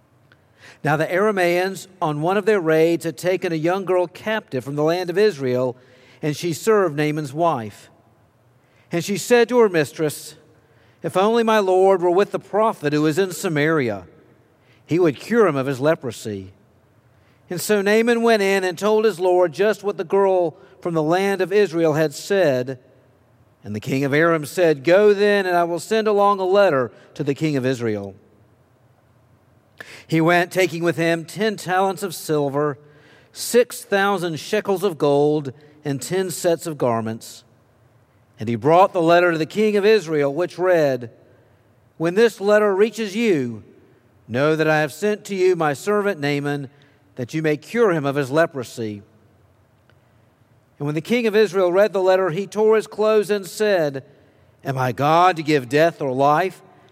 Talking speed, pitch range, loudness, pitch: 175 wpm, 130-190 Hz, -19 LUFS, 160 Hz